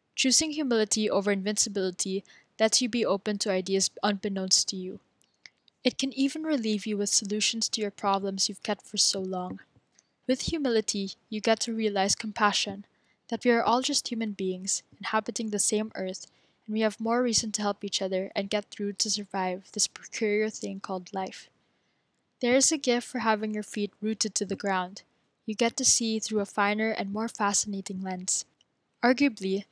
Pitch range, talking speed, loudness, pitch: 195-230 Hz, 180 wpm, -28 LUFS, 210 Hz